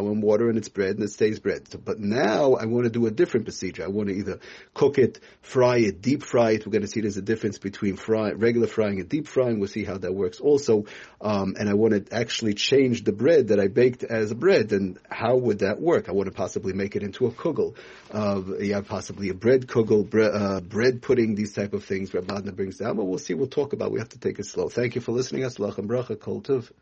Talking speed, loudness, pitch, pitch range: 255 wpm, -24 LUFS, 105 Hz, 100-120 Hz